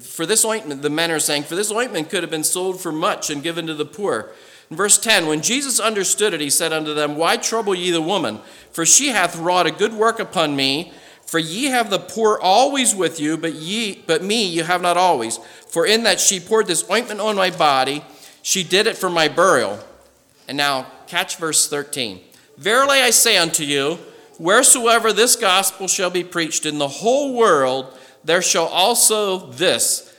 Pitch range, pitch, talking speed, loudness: 160-220 Hz, 180 Hz, 205 wpm, -17 LUFS